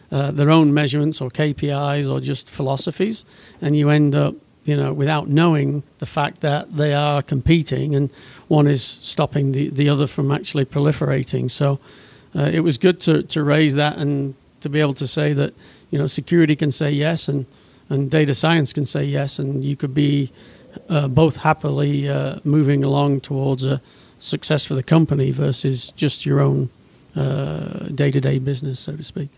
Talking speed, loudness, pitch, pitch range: 180 wpm, -19 LUFS, 145 Hz, 140-150 Hz